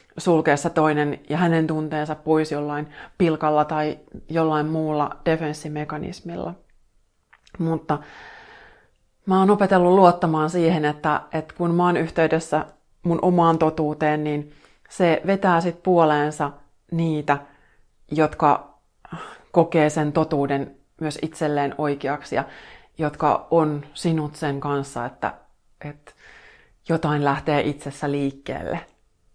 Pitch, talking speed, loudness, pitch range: 155 Hz, 105 wpm, -22 LUFS, 150-165 Hz